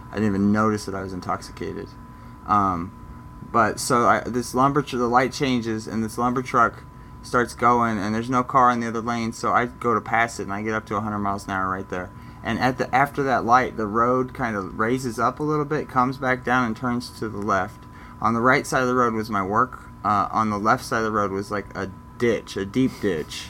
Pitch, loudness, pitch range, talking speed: 115 Hz, -23 LUFS, 105-125 Hz, 250 wpm